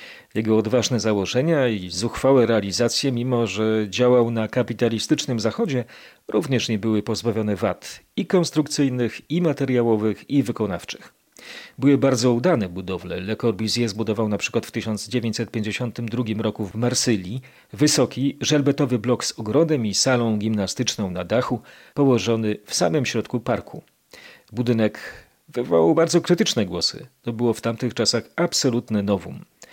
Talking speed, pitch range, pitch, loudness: 125 wpm, 110-130 Hz, 120 Hz, -22 LUFS